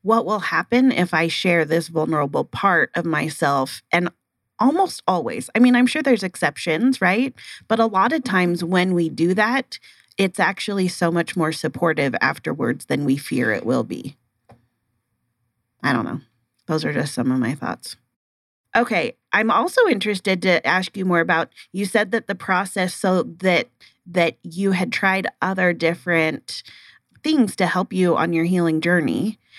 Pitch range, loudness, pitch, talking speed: 160-200 Hz, -20 LUFS, 180 Hz, 170 wpm